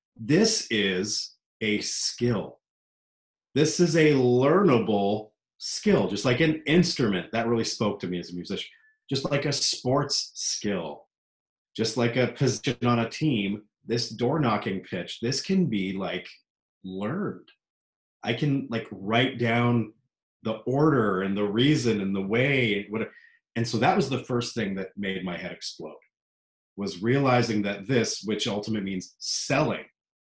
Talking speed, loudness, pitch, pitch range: 150 wpm, -26 LUFS, 115 Hz, 100-135 Hz